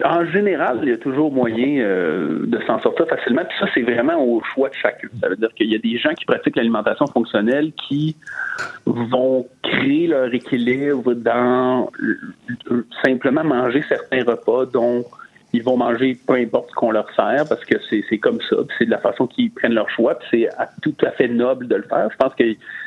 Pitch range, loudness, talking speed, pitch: 120-145 Hz, -19 LUFS, 215 wpm, 125 Hz